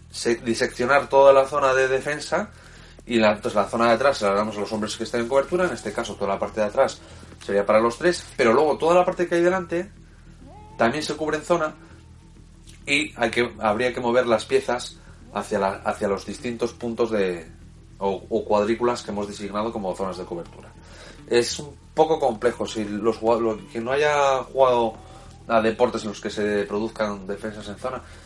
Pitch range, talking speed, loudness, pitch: 100-130 Hz, 200 wpm, -23 LUFS, 110 Hz